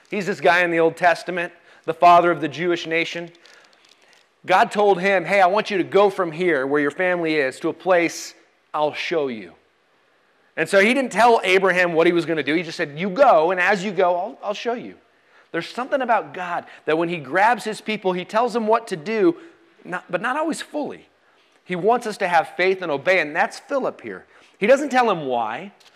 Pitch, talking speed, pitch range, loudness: 180 Hz, 225 wpm, 170-215 Hz, -20 LUFS